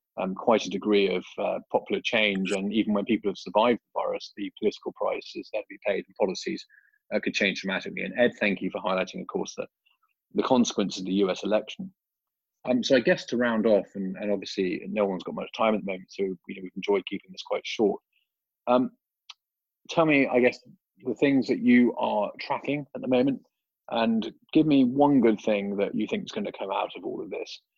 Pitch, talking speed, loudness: 125 Hz, 220 wpm, -26 LUFS